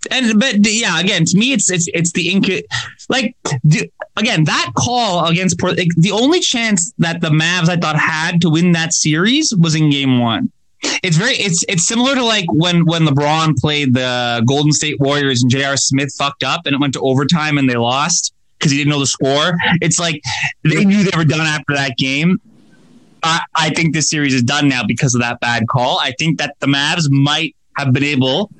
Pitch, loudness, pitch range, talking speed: 160 Hz, -14 LUFS, 140-180 Hz, 210 wpm